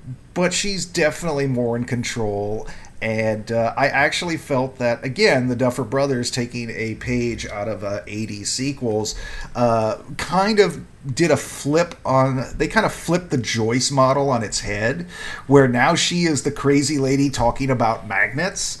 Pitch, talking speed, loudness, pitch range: 130 Hz, 165 wpm, -20 LUFS, 115-145 Hz